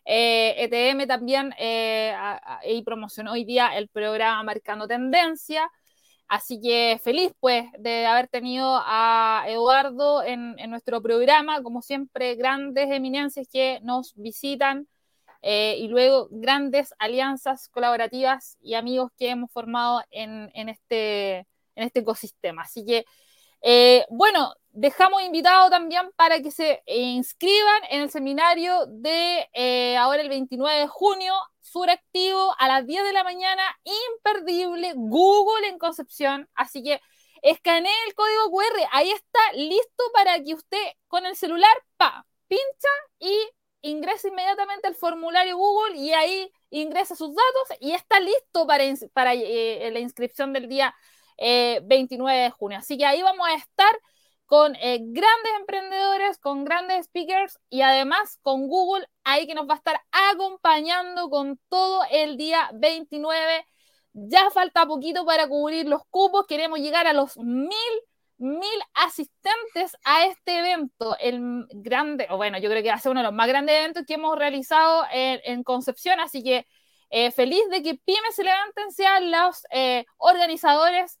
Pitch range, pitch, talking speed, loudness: 250-360 Hz, 295 Hz, 155 wpm, -22 LUFS